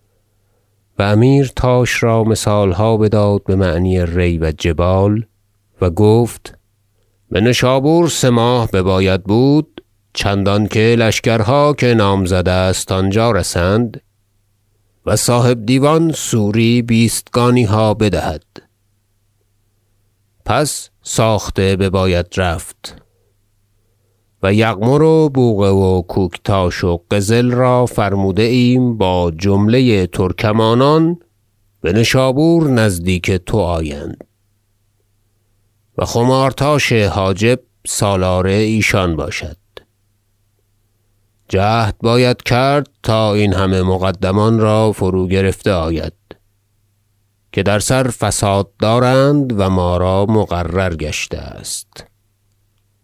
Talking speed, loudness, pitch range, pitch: 100 wpm, -14 LUFS, 95-115 Hz, 105 Hz